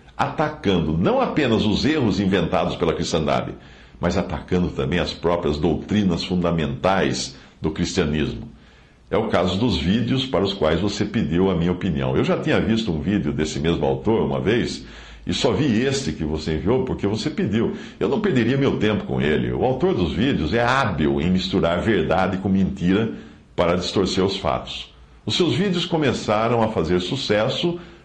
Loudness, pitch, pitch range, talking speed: -21 LUFS, 90 Hz, 75-110 Hz, 170 wpm